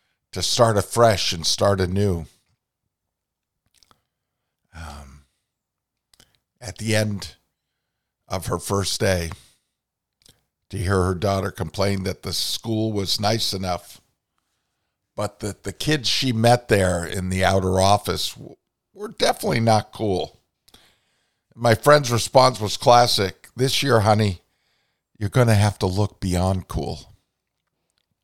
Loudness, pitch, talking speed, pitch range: -21 LUFS, 100 Hz, 120 wpm, 95-115 Hz